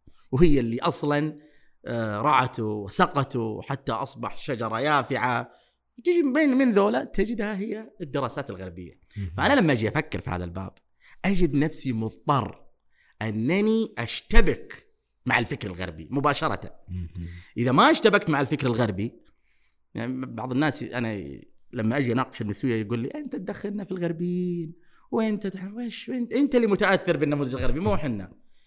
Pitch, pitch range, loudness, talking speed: 140 Hz, 110-190 Hz, -26 LUFS, 130 wpm